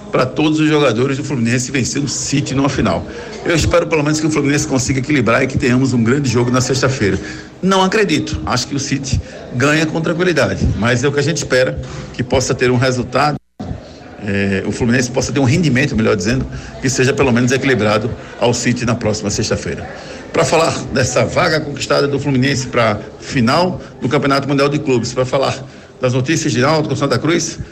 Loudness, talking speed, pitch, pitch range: -15 LUFS, 195 wpm, 130 Hz, 120-145 Hz